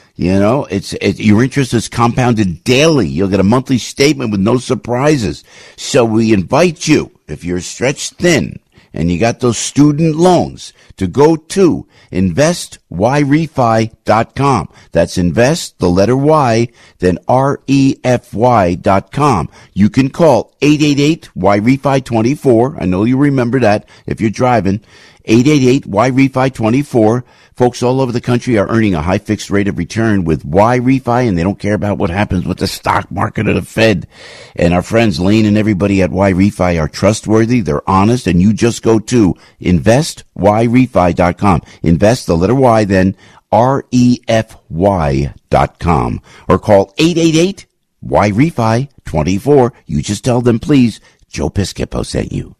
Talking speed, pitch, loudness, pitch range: 165 wpm, 115 Hz, -12 LUFS, 95-130 Hz